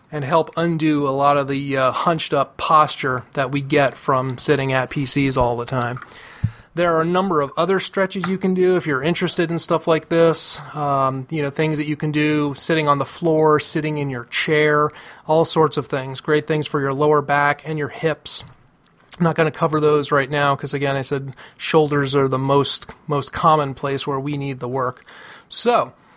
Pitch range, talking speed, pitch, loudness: 140-160 Hz, 210 wpm, 145 Hz, -19 LUFS